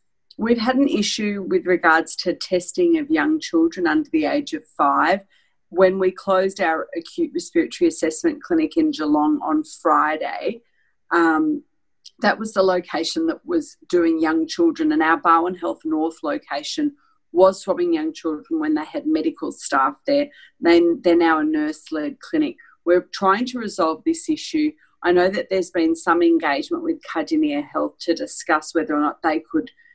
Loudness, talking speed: -20 LUFS, 170 wpm